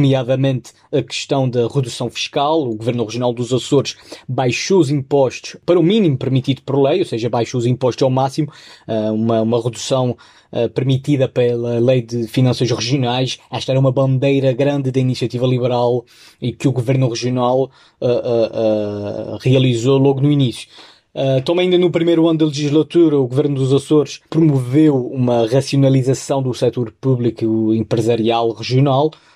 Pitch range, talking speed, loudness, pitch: 120-140 Hz, 150 wpm, -17 LUFS, 130 Hz